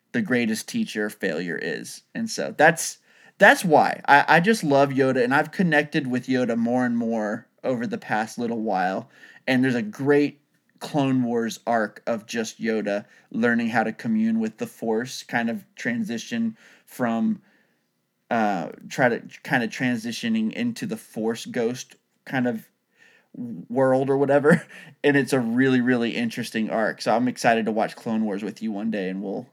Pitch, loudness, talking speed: 130 Hz, -23 LUFS, 170 wpm